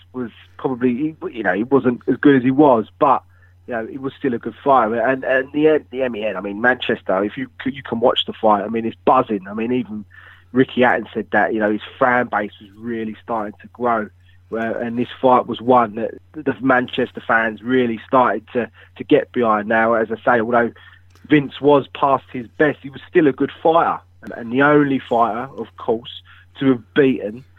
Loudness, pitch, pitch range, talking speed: -18 LUFS, 120 Hz, 105-130 Hz, 210 wpm